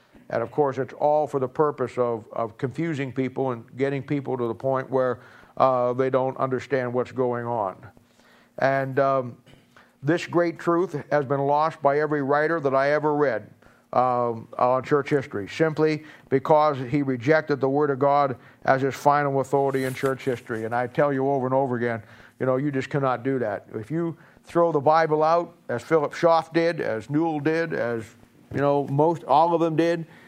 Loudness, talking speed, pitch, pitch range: -24 LUFS, 190 wpm, 140 Hz, 130-150 Hz